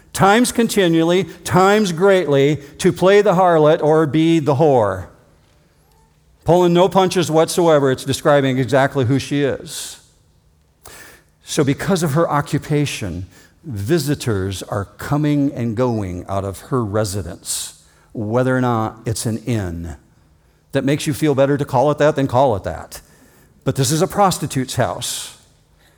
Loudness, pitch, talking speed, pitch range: -17 LUFS, 140 Hz, 140 wpm, 110-165 Hz